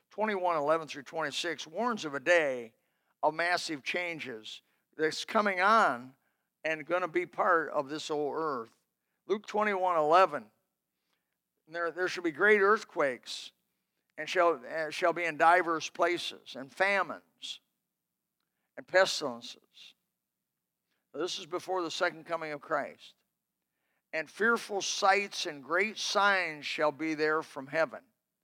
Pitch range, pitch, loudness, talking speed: 155-195 Hz, 175 Hz, -30 LUFS, 135 wpm